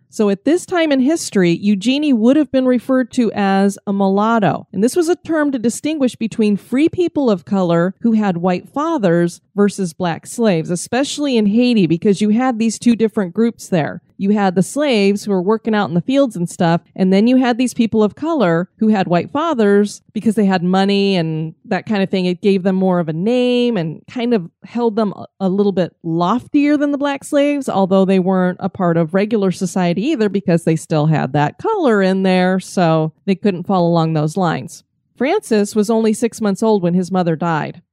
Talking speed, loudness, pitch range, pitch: 210 wpm, -16 LUFS, 185-235 Hz, 200 Hz